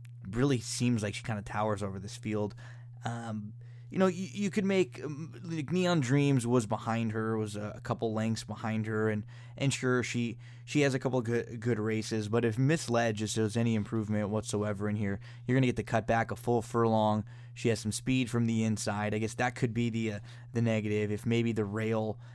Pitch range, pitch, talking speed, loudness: 110-120 Hz, 115 Hz, 220 wpm, -32 LUFS